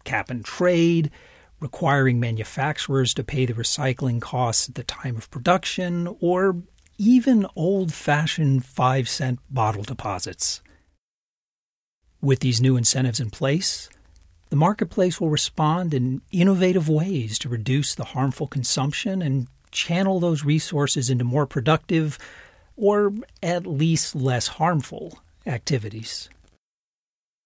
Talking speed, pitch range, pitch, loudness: 120 wpm, 125-170 Hz, 140 Hz, -23 LUFS